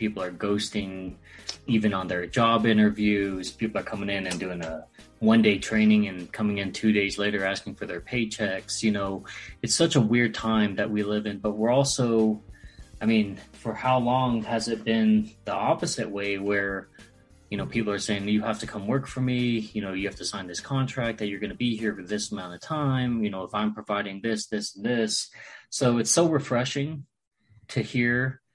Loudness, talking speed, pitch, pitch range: -26 LUFS, 210 wpm, 105 Hz, 100-115 Hz